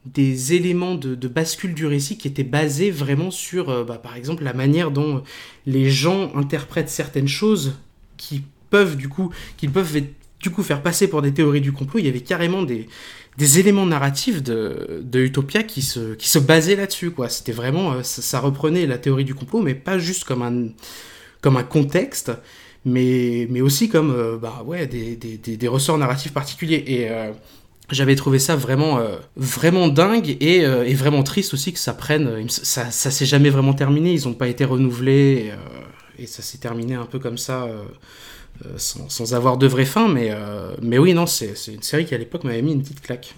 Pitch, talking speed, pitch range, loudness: 140 Hz, 210 wpm, 125-160 Hz, -20 LUFS